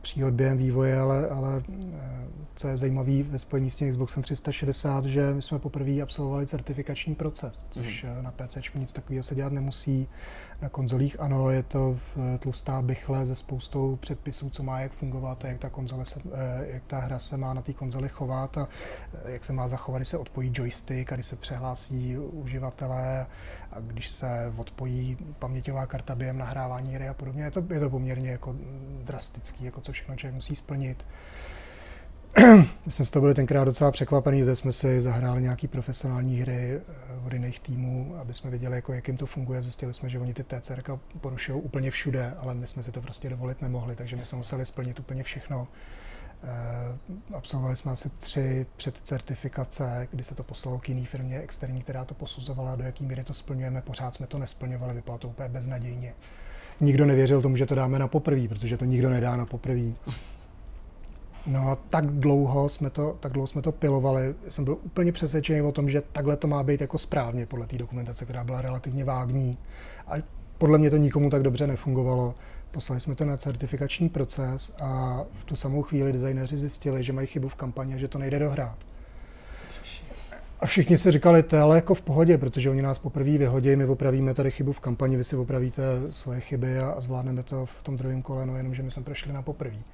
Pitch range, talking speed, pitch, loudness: 125-140 Hz, 195 wpm, 130 Hz, -27 LUFS